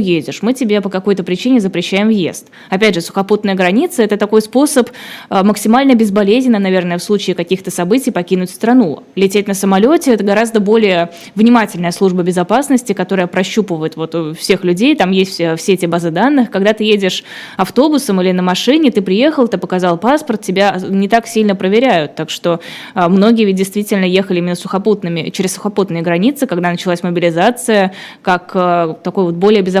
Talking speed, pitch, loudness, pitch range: 165 wpm, 195 Hz, -13 LUFS, 180-225 Hz